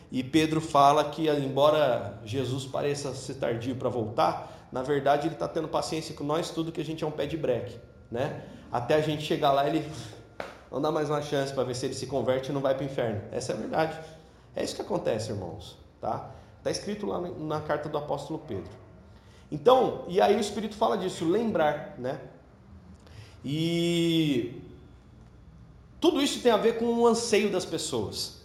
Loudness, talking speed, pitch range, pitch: -28 LUFS, 190 wpm, 130-165 Hz, 150 Hz